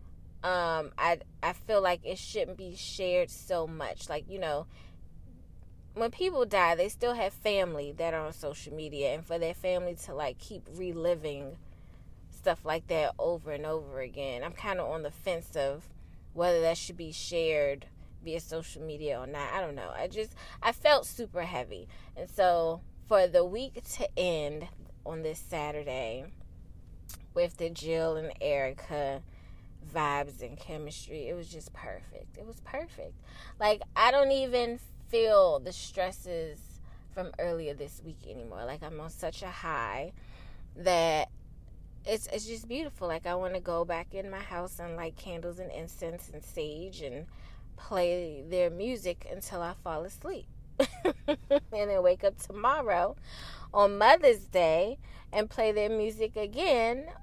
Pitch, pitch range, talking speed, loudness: 170 Hz, 145-200 Hz, 160 wpm, -31 LUFS